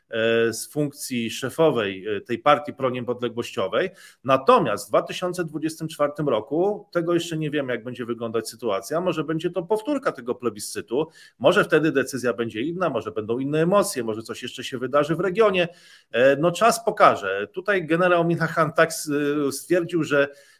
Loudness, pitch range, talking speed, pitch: -23 LUFS, 125-175 Hz, 145 wpm, 150 Hz